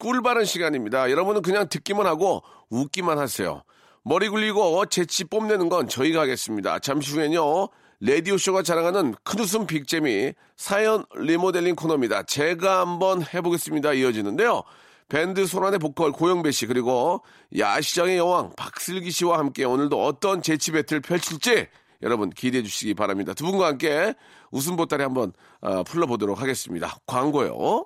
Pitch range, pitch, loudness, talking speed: 140-190 Hz, 170 Hz, -23 LUFS, 365 characters per minute